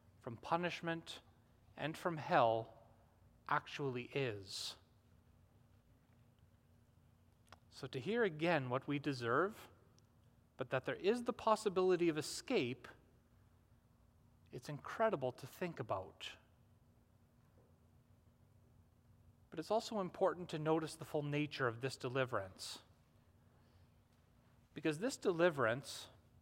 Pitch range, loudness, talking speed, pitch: 110-155 Hz, -40 LUFS, 95 wpm, 120 Hz